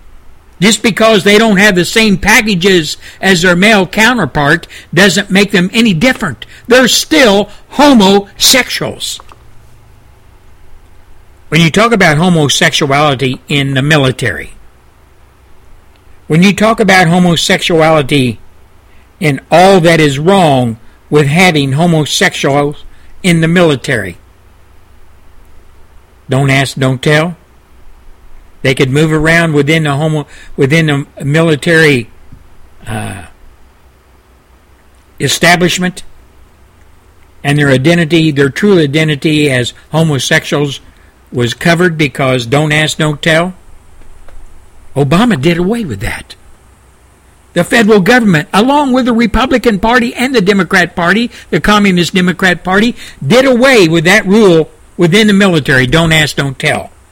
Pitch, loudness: 150 Hz, -9 LUFS